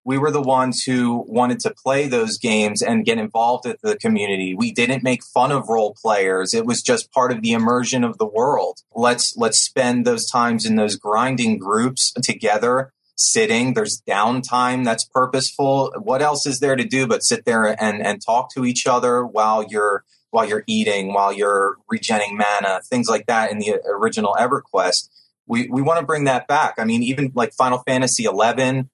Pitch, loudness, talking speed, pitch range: 130 Hz, -19 LUFS, 195 wpm, 115-150 Hz